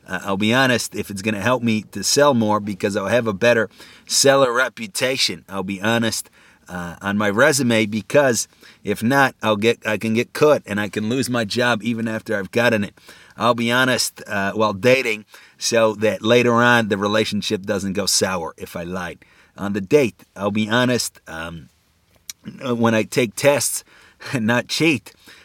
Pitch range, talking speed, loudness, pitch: 105-120 Hz, 185 wpm, -19 LUFS, 110 Hz